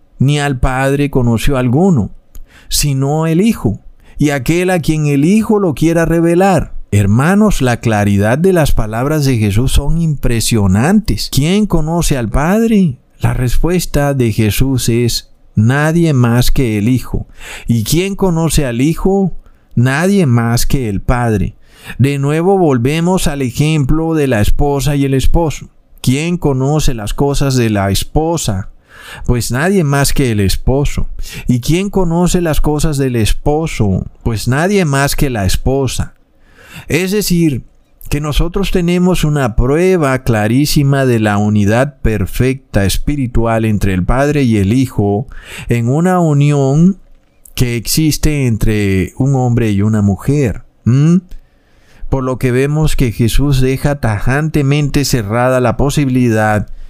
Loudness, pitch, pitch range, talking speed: -13 LUFS, 135 Hz, 115-155 Hz, 135 wpm